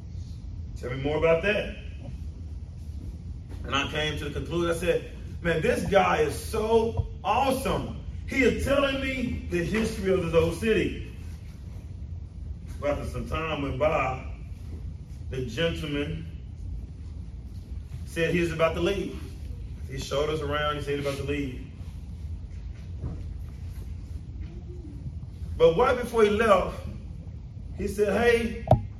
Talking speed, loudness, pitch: 125 wpm, -27 LUFS, 90 Hz